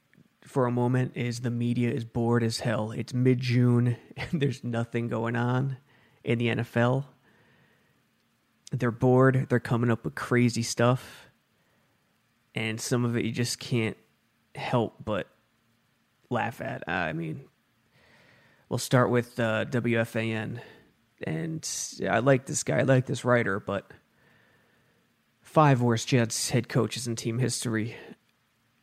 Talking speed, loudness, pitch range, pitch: 135 wpm, -27 LUFS, 115-125 Hz, 120 Hz